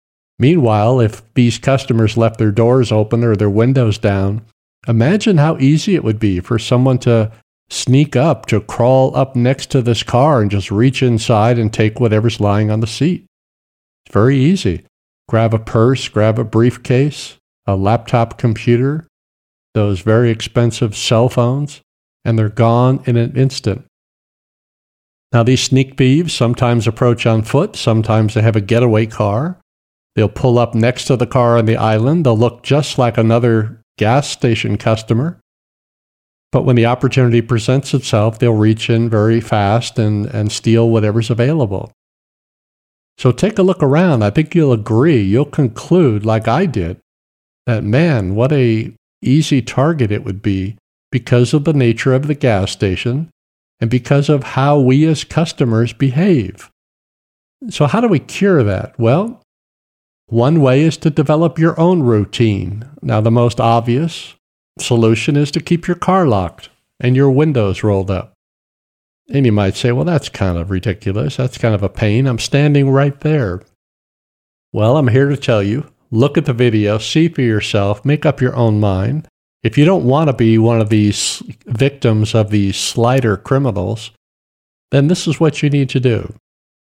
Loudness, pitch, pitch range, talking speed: -14 LUFS, 120 Hz, 110-140 Hz, 165 wpm